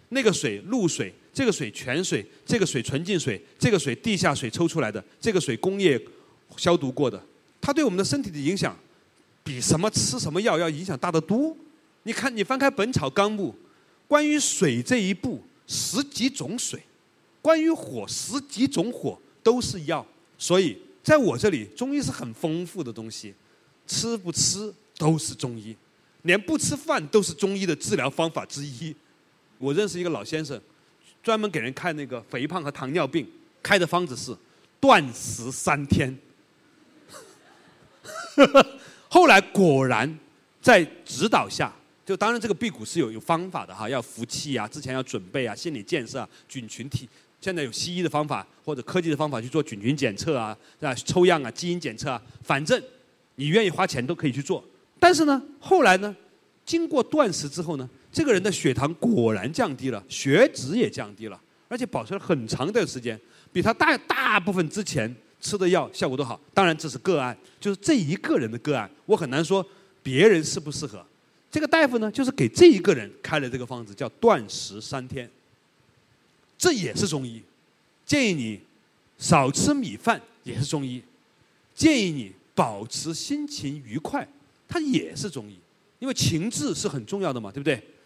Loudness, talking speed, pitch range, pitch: -24 LUFS, 260 characters per minute, 130-210 Hz, 165 Hz